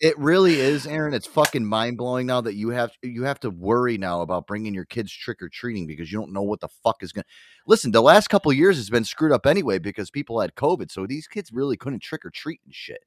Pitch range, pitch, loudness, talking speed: 105-150 Hz, 120 Hz, -22 LUFS, 250 wpm